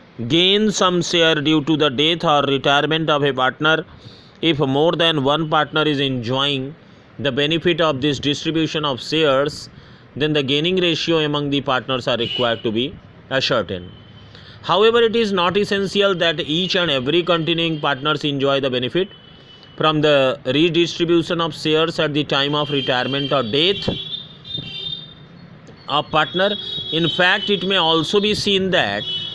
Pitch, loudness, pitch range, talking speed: 155 Hz, -18 LUFS, 140-170 Hz, 150 wpm